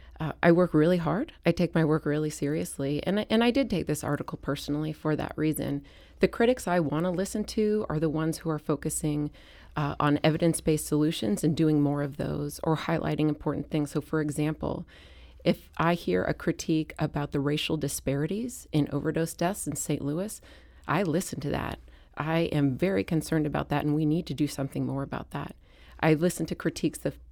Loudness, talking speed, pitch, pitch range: -28 LUFS, 200 wpm, 155 Hz, 145-165 Hz